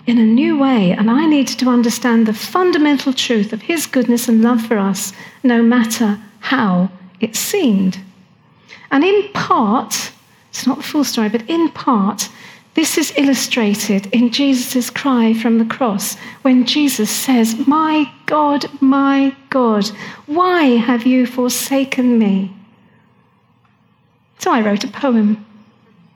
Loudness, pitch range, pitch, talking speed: -15 LUFS, 215-275 Hz, 240 Hz, 140 wpm